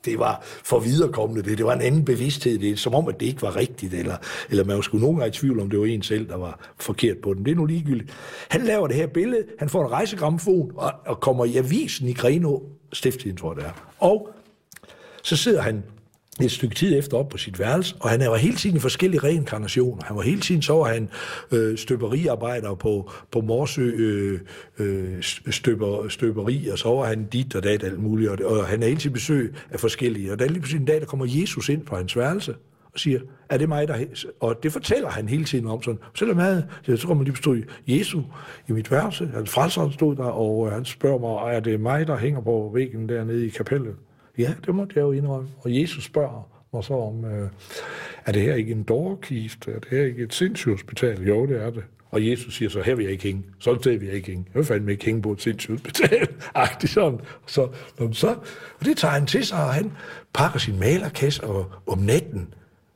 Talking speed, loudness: 225 wpm, -24 LUFS